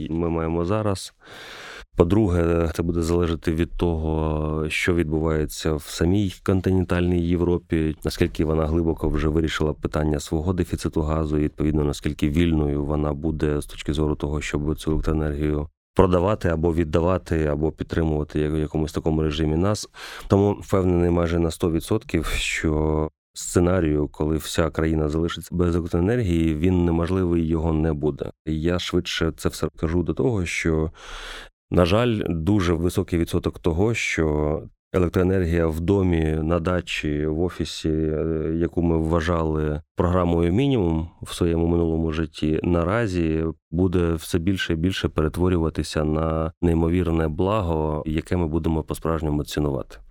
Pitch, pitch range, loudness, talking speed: 80 Hz, 80-90 Hz, -23 LUFS, 135 wpm